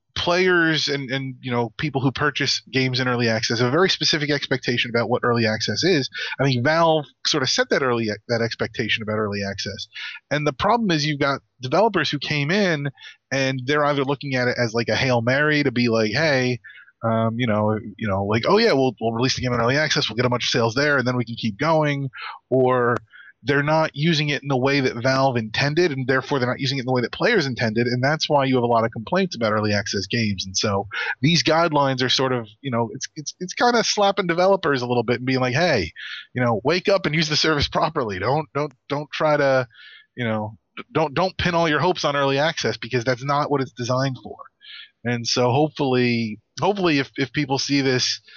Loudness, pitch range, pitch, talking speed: -21 LUFS, 120-150 Hz, 130 Hz, 235 wpm